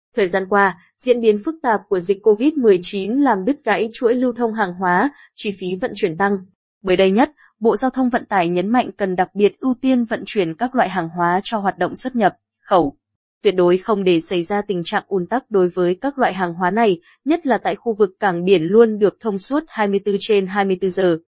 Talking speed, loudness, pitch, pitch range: 230 wpm, -18 LUFS, 205 Hz, 185-235 Hz